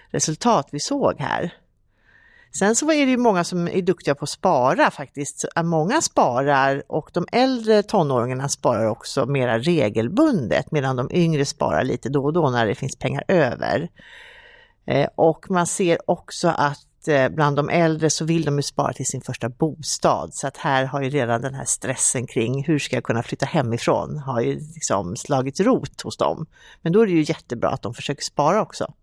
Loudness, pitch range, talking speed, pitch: -21 LUFS, 135-170 Hz, 190 wpm, 145 Hz